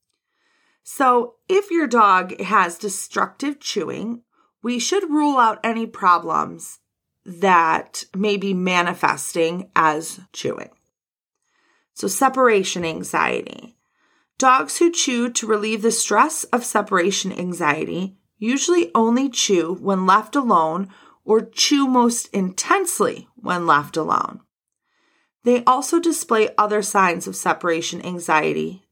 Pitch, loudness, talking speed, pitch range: 210 Hz, -19 LUFS, 110 wpm, 180-255 Hz